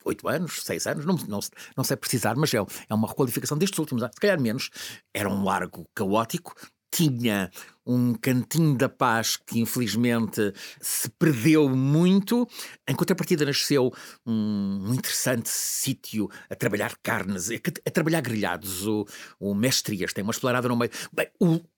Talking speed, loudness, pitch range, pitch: 150 wpm, -26 LUFS, 110-155 Hz, 125 Hz